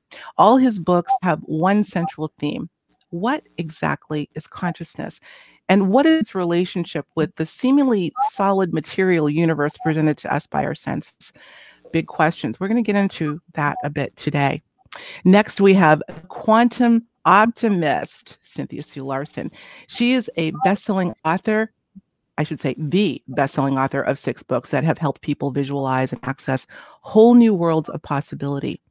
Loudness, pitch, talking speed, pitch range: -20 LUFS, 165 Hz, 145 wpm, 150-200 Hz